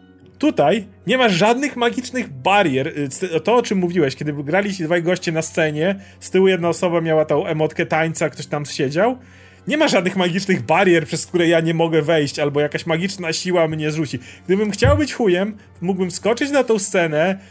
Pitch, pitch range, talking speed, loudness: 170 Hz, 155-195 Hz, 185 wpm, -18 LUFS